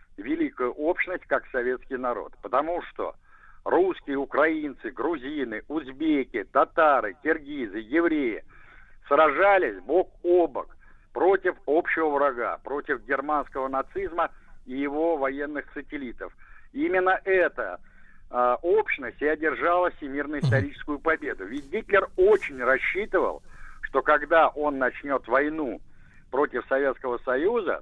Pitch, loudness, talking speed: 165 Hz, -25 LUFS, 105 wpm